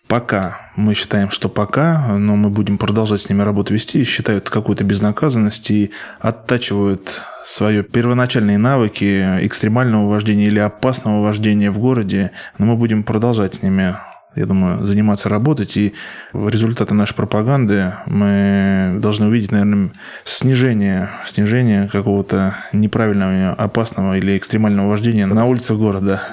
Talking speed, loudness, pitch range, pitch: 130 wpm, -16 LUFS, 100-110 Hz, 105 Hz